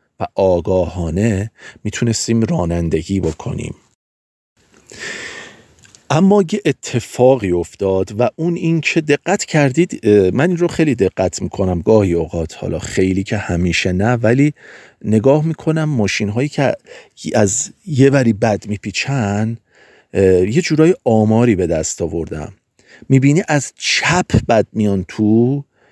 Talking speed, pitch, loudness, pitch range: 115 wpm, 110 Hz, -16 LUFS, 95-145 Hz